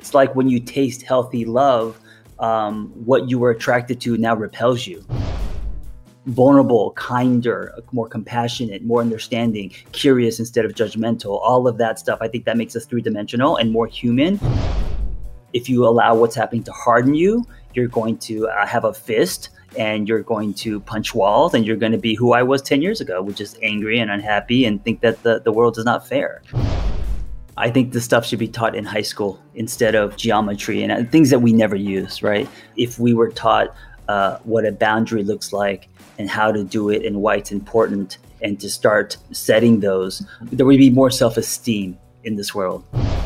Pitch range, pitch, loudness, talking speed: 105-120 Hz, 115 Hz, -18 LUFS, 190 wpm